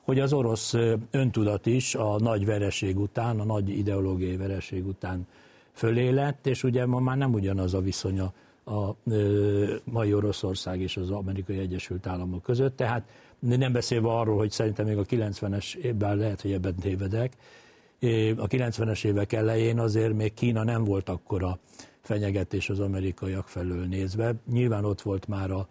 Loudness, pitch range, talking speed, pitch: -28 LUFS, 95-115 Hz, 155 wpm, 105 Hz